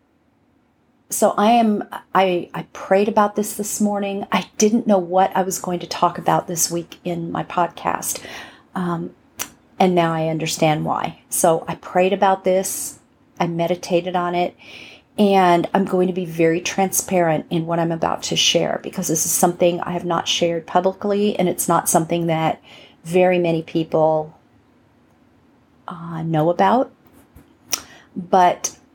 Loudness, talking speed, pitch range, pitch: -19 LUFS, 155 wpm, 170-190 Hz, 180 Hz